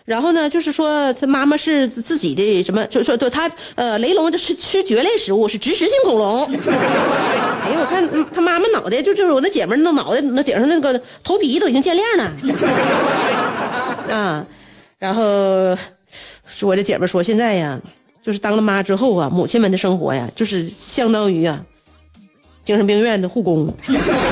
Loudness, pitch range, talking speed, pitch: -17 LUFS, 200-320 Hz, 265 characters per minute, 250 Hz